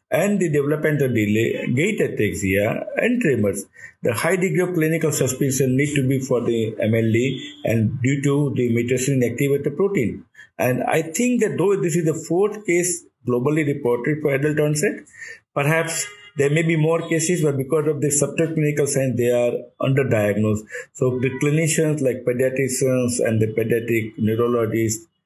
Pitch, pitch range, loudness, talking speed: 140 Hz, 120-160 Hz, -20 LUFS, 160 wpm